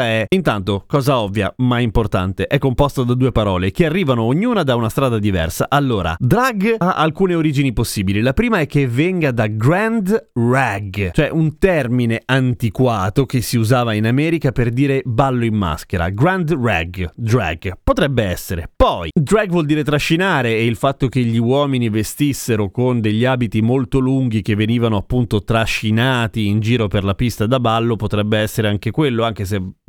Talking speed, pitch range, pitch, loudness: 170 wpm, 110-140 Hz, 120 Hz, -17 LUFS